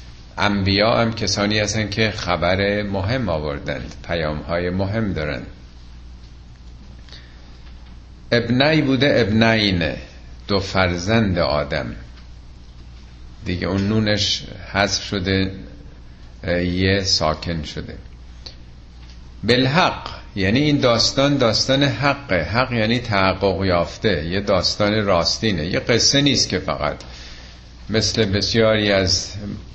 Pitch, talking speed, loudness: 95 Hz, 95 wpm, -19 LUFS